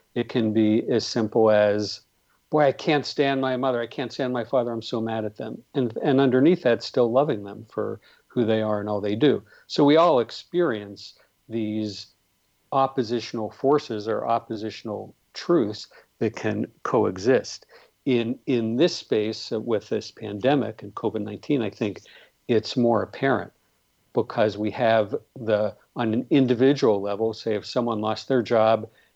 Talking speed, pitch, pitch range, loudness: 160 wpm, 115 Hz, 105-130 Hz, -24 LUFS